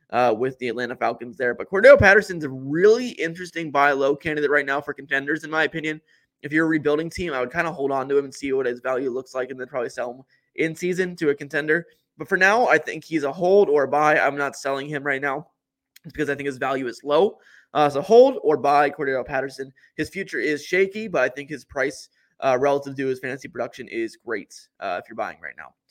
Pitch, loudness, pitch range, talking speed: 145 Hz, -22 LUFS, 135-160 Hz, 250 wpm